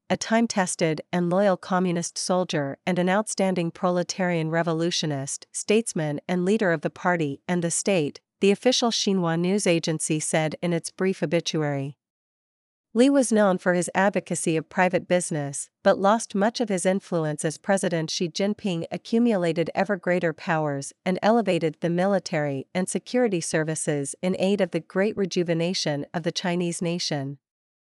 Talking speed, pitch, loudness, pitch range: 155 wpm, 180 Hz, -24 LUFS, 160-195 Hz